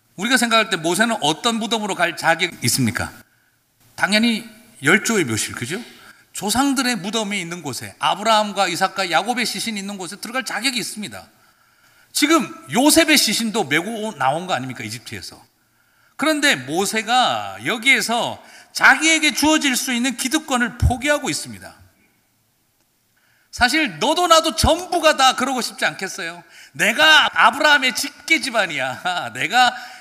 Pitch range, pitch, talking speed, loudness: 190-285 Hz, 230 Hz, 320 characters per minute, -18 LUFS